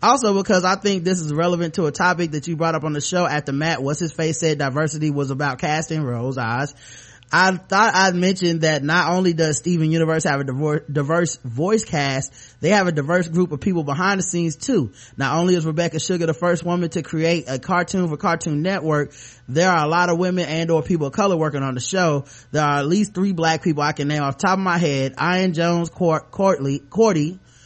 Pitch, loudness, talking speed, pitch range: 165 Hz, -20 LUFS, 230 wpm, 145-180 Hz